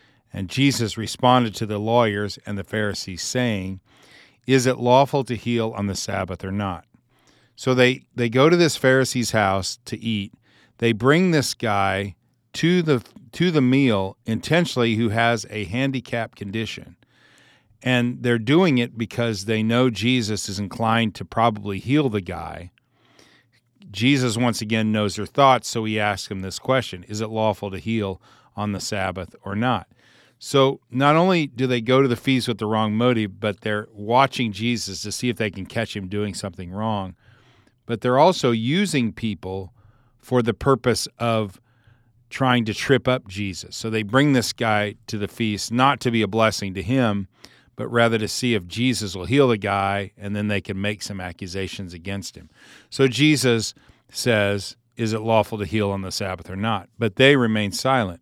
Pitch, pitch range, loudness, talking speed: 115 Hz, 105-125 Hz, -22 LUFS, 180 wpm